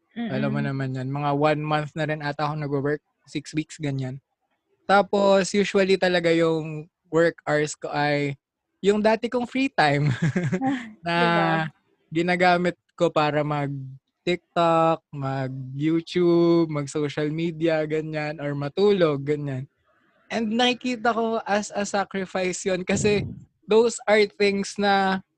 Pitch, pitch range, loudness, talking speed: 165 Hz, 150-195 Hz, -23 LUFS, 125 wpm